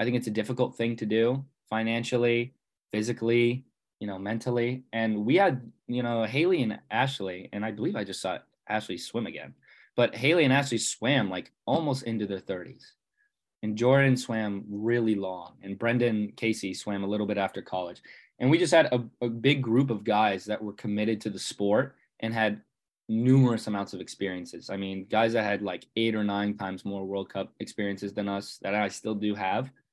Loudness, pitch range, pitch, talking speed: -28 LUFS, 100-120 Hz, 110 Hz, 195 wpm